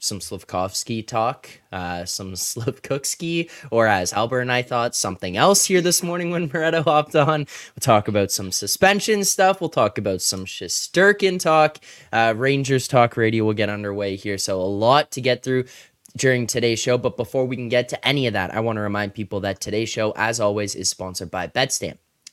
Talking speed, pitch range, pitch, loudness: 195 wpm, 105-145 Hz, 120 Hz, -21 LUFS